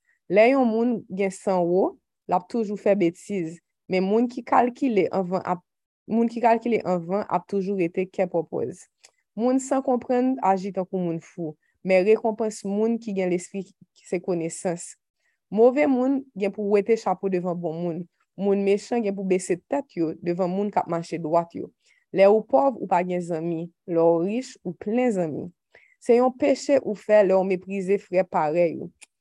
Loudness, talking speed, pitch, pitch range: -24 LUFS, 175 wpm, 195 Hz, 180-230 Hz